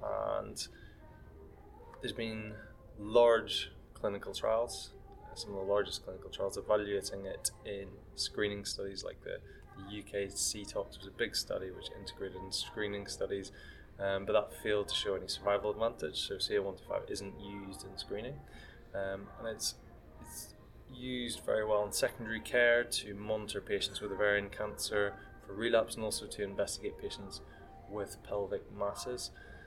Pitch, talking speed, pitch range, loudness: 105 Hz, 145 wpm, 100-115 Hz, -36 LUFS